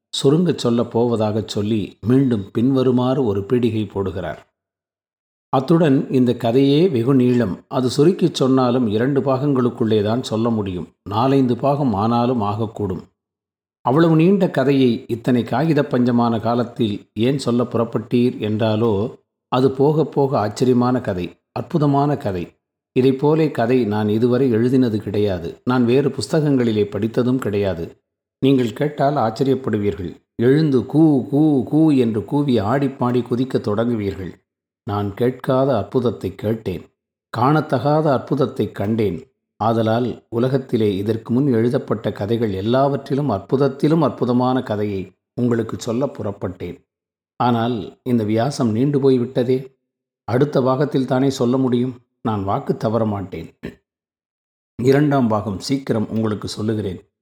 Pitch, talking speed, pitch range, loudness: 120 Hz, 110 wpm, 105-135 Hz, -19 LUFS